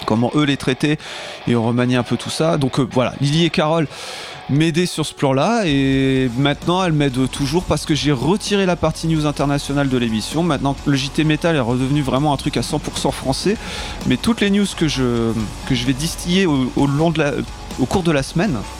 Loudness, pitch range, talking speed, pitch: -18 LUFS, 135-165 Hz, 215 wpm, 145 Hz